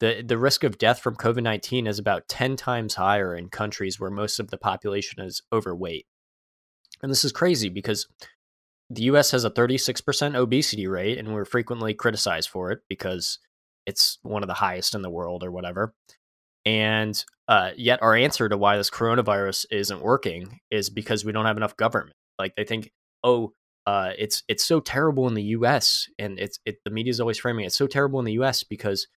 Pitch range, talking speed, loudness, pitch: 105-125 Hz, 205 wpm, -24 LUFS, 110 Hz